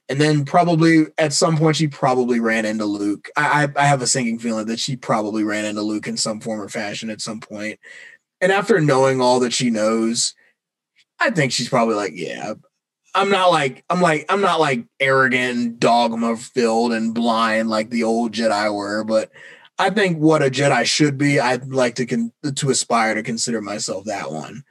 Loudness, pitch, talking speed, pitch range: -19 LUFS, 120 Hz, 200 wpm, 110-145 Hz